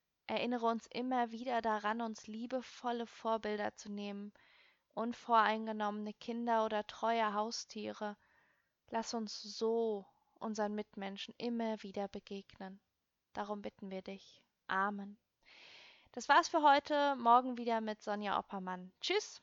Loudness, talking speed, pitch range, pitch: -37 LUFS, 115 wpm, 205-235 Hz, 220 Hz